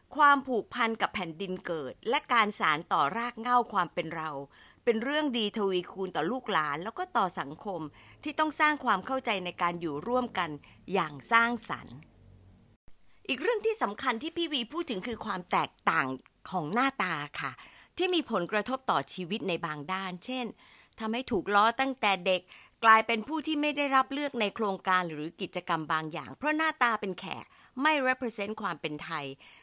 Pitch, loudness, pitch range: 210 Hz, -30 LUFS, 175-255 Hz